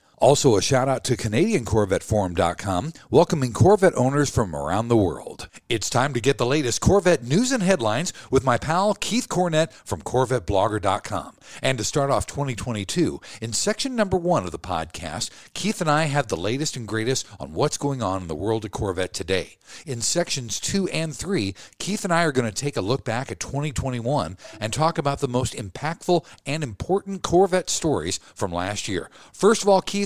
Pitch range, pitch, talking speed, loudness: 110-170 Hz, 130 Hz, 190 wpm, -23 LUFS